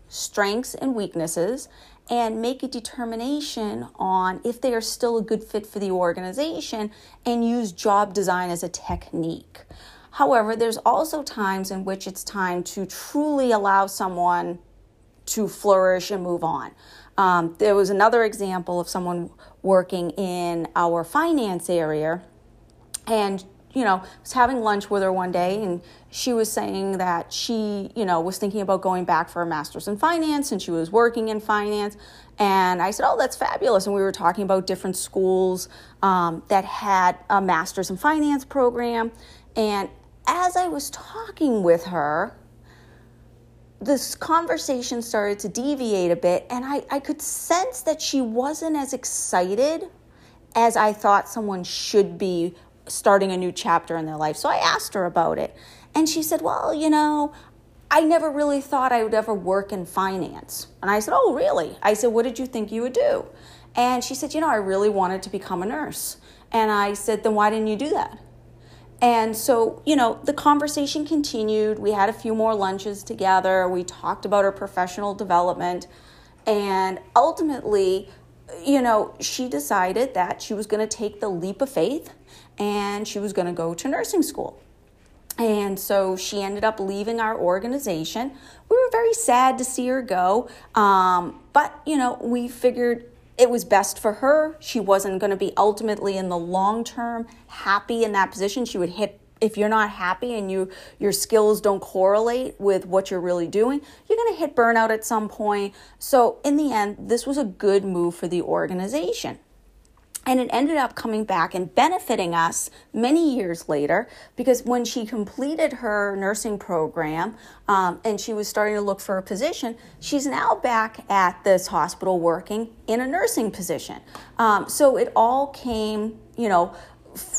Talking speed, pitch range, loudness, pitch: 175 wpm, 185-245 Hz, -23 LUFS, 210 Hz